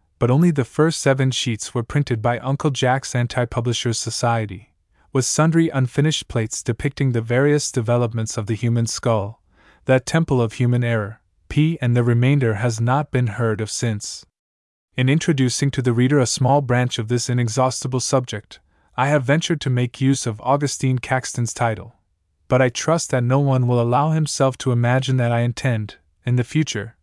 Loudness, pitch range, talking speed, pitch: -20 LUFS, 115-135 Hz, 180 wpm, 125 Hz